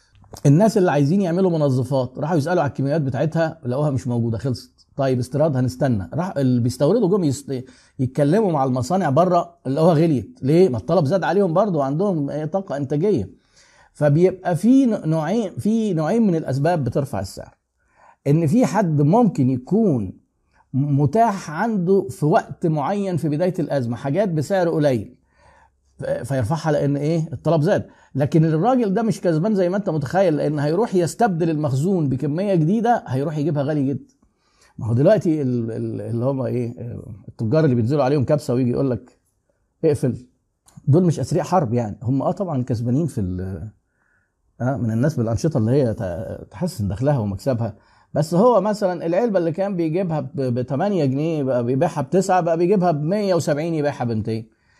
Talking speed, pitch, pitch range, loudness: 150 wpm, 150 Hz, 130-175 Hz, -20 LUFS